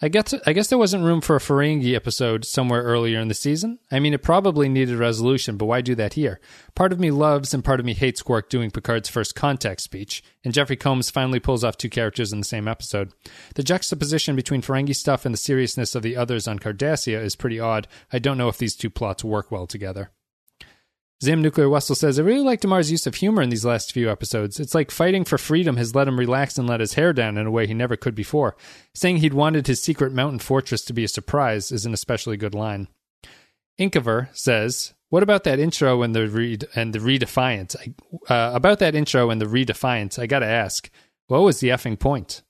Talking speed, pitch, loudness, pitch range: 225 wpm, 125 Hz, -21 LUFS, 115-145 Hz